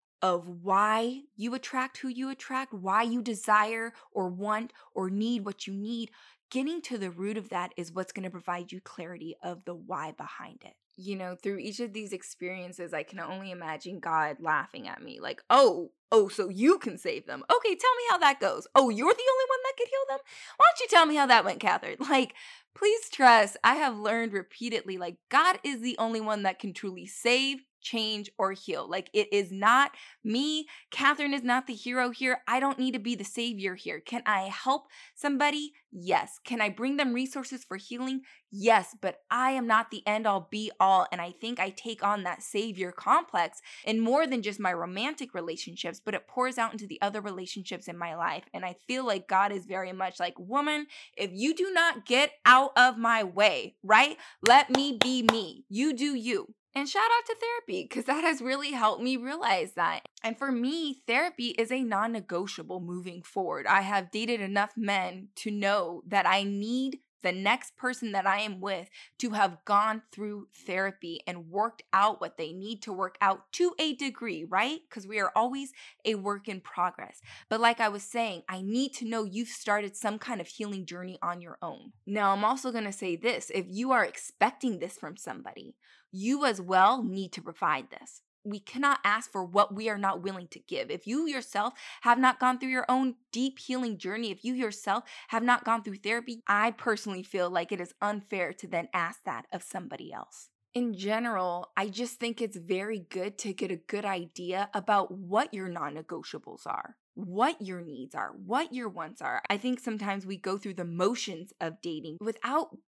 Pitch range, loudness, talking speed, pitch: 190-255 Hz, -29 LUFS, 205 wpm, 215 Hz